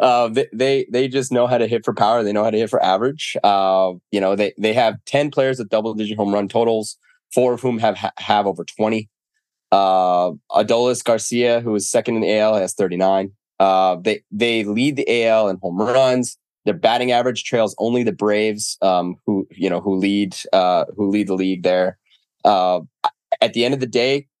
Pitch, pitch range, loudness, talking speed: 110 Hz, 95-120 Hz, -18 LUFS, 210 wpm